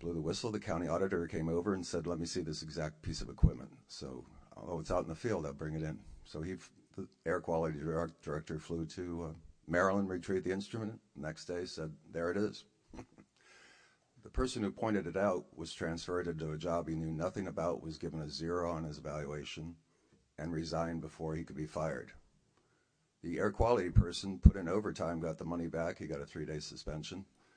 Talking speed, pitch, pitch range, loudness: 205 wpm, 85 Hz, 80-90 Hz, -38 LUFS